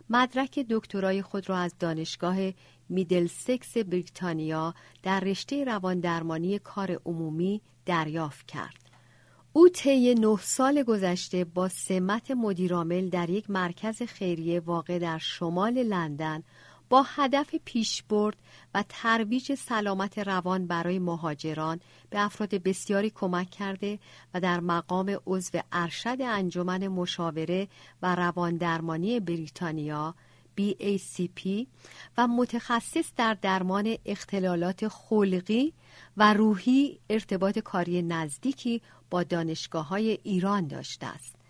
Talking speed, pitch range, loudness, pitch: 110 wpm, 175-215 Hz, -29 LUFS, 190 Hz